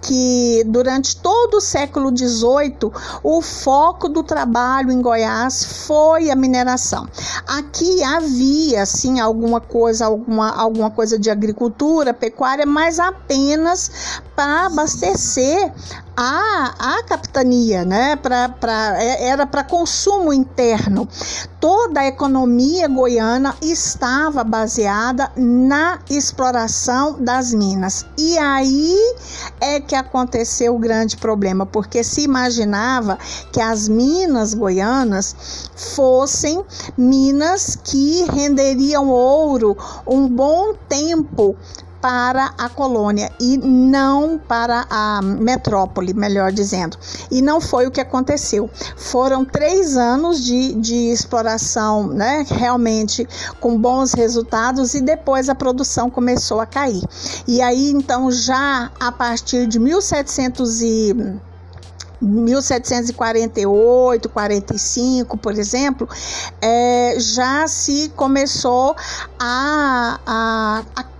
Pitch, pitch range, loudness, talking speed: 255 Hz, 230-280 Hz, -16 LUFS, 105 wpm